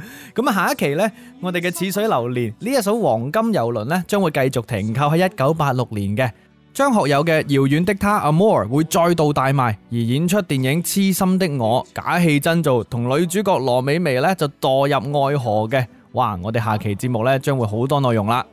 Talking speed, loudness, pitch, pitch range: 300 characters per minute, -19 LUFS, 140 Hz, 125-180 Hz